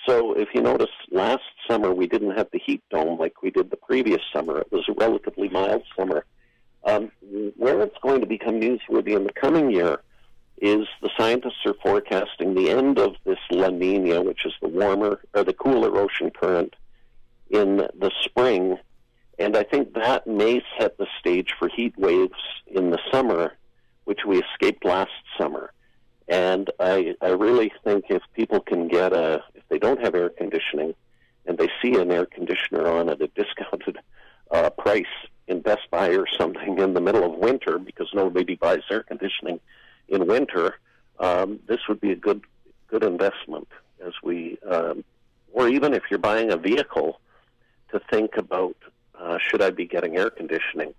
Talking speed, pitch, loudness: 175 wpm, 115 Hz, -23 LUFS